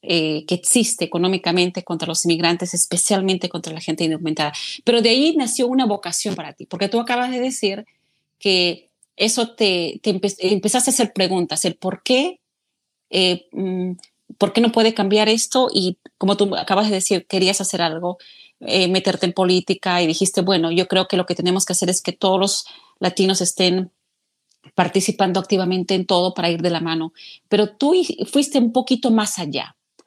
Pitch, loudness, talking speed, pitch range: 190 Hz, -19 LUFS, 180 wpm, 175-210 Hz